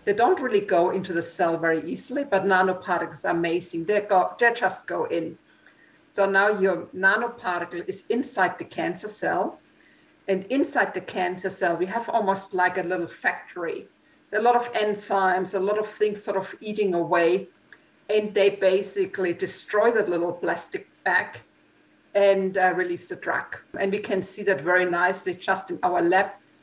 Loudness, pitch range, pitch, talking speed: -24 LUFS, 185-215 Hz, 195 Hz, 170 wpm